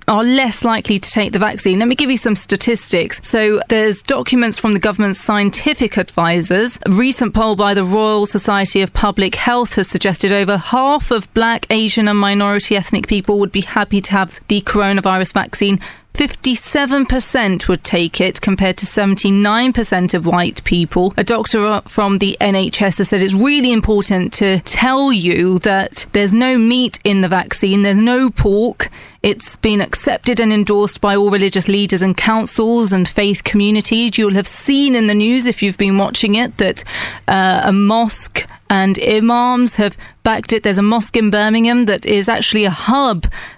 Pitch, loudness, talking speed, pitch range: 210 Hz, -13 LUFS, 175 wpm, 195-230 Hz